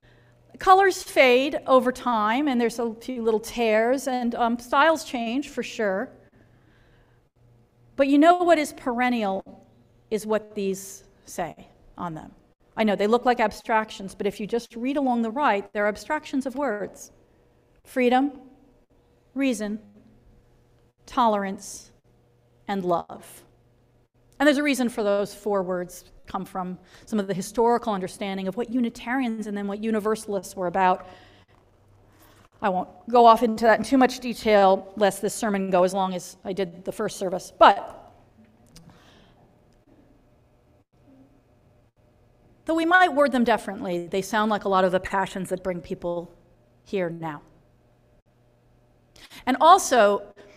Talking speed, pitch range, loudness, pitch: 140 wpm, 160-240 Hz, -23 LUFS, 205 Hz